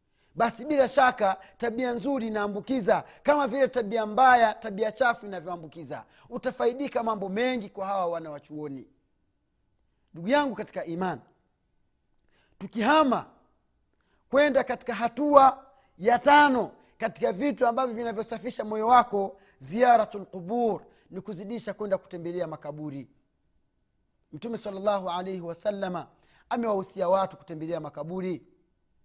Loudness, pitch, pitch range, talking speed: -26 LUFS, 215 Hz, 180-245 Hz, 105 wpm